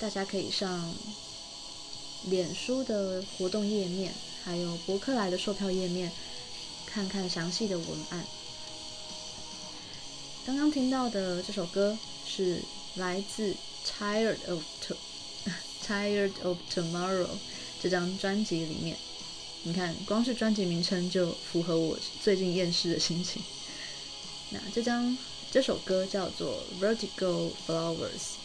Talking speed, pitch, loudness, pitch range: 235 characters per minute, 190 Hz, -32 LUFS, 180-205 Hz